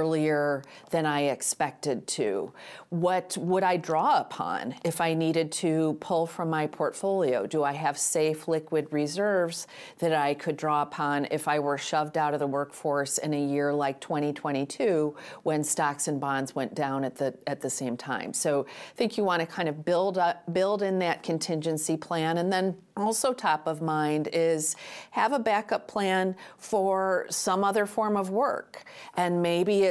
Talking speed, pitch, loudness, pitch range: 180 wpm, 160 Hz, -28 LUFS, 145-185 Hz